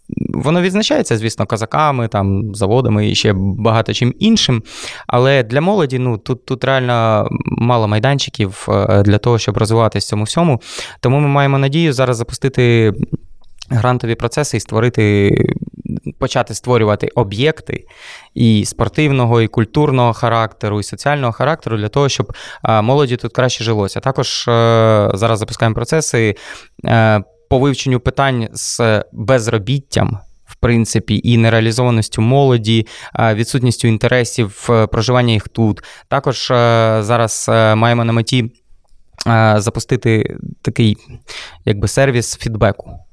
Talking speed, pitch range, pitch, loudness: 115 wpm, 110-130 Hz, 115 Hz, -14 LUFS